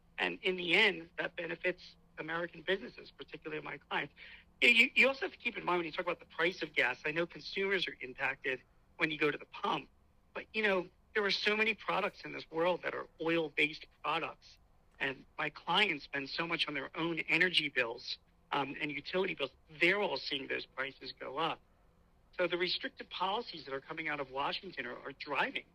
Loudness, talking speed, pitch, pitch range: -34 LUFS, 205 wpm, 165 Hz, 155-185 Hz